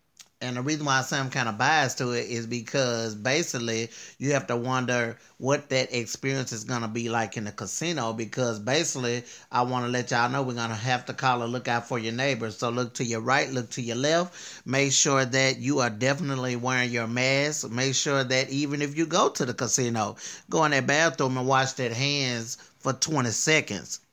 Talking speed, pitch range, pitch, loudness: 215 wpm, 120-135 Hz, 125 Hz, -26 LUFS